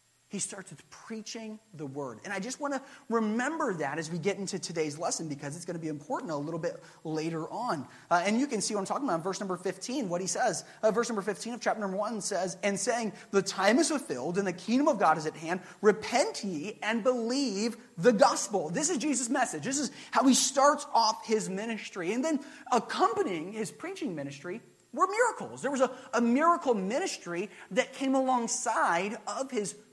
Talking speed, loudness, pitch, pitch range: 215 wpm, -30 LUFS, 215 Hz, 180-260 Hz